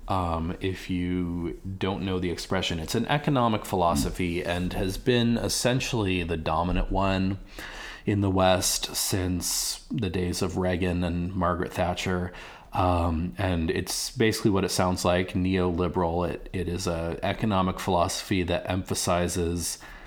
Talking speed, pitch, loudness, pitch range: 140 wpm, 90 Hz, -27 LUFS, 90-95 Hz